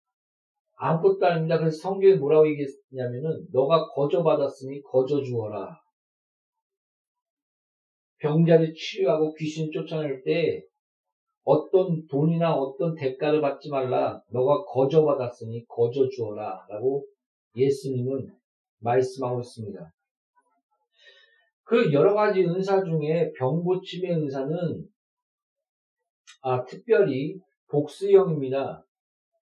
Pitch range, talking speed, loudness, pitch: 135-225 Hz, 235 characters per minute, -25 LUFS, 160 Hz